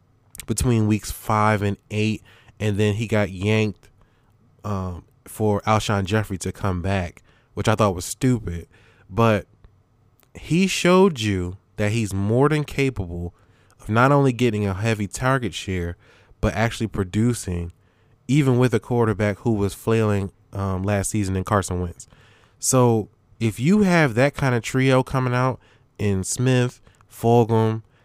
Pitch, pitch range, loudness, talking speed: 110 Hz, 100-120 Hz, -22 LUFS, 145 wpm